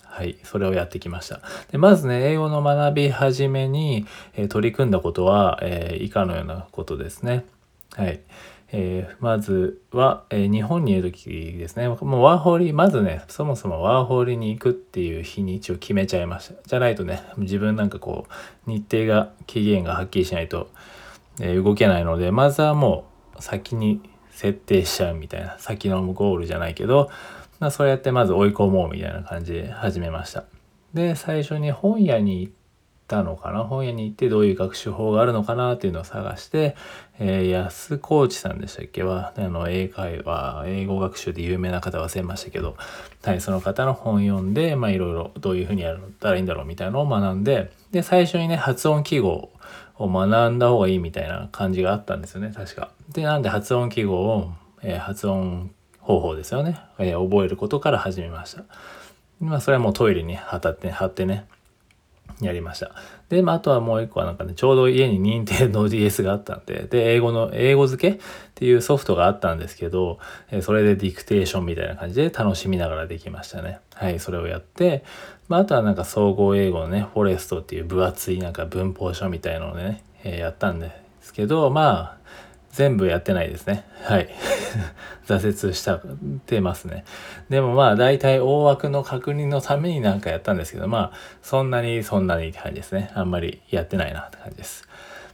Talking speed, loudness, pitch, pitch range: 390 characters per minute, -22 LUFS, 100 Hz, 95-130 Hz